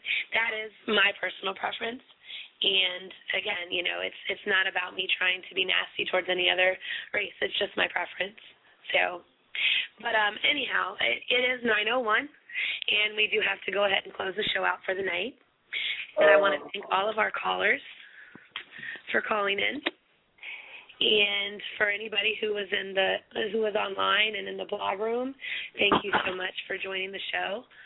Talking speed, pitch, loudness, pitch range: 185 wpm, 205 Hz, -27 LUFS, 190-220 Hz